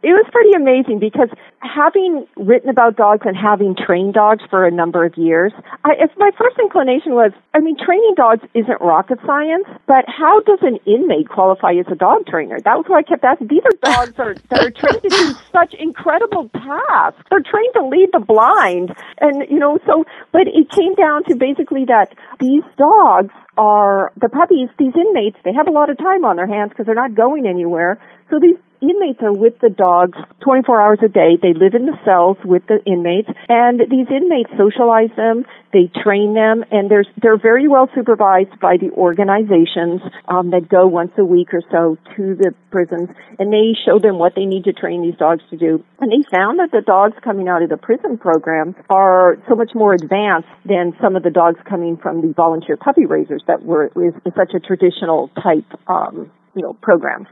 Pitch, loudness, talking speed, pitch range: 225 Hz, -13 LUFS, 205 wpm, 185-295 Hz